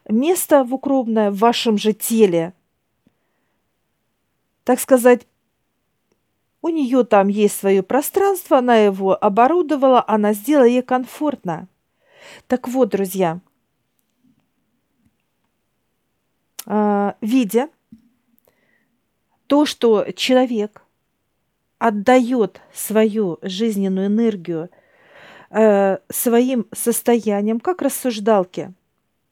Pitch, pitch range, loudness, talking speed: 230 Hz, 205-255 Hz, -17 LUFS, 75 wpm